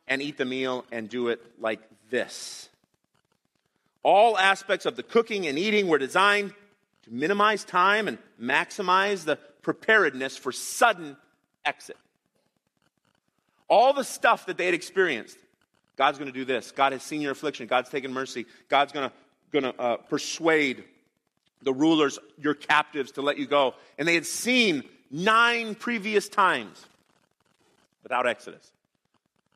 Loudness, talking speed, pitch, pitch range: -25 LUFS, 140 wpm, 150 Hz, 135-200 Hz